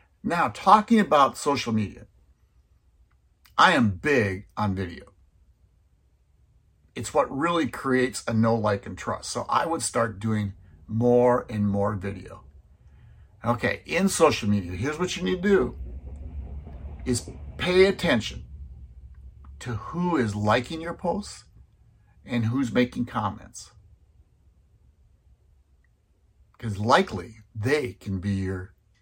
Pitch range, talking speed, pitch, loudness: 80-120 Hz, 120 wpm, 100 Hz, -25 LUFS